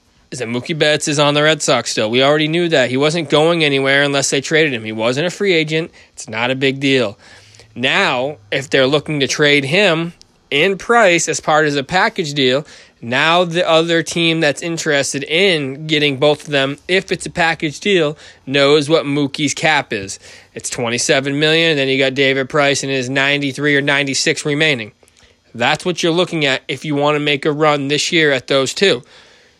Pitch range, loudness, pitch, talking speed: 135-160 Hz, -15 LUFS, 150 Hz, 210 wpm